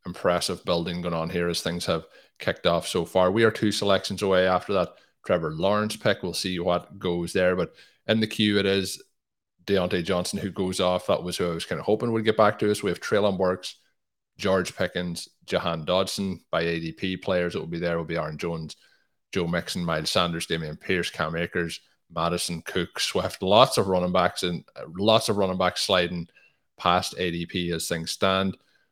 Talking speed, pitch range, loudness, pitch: 200 wpm, 85-95 Hz, -25 LUFS, 90 Hz